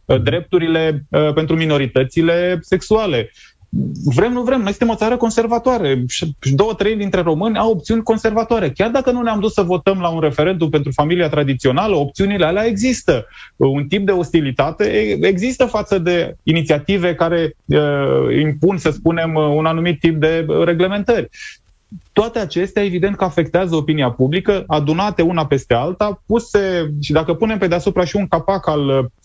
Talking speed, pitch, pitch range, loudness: 150 wpm, 175 Hz, 155-210 Hz, -16 LUFS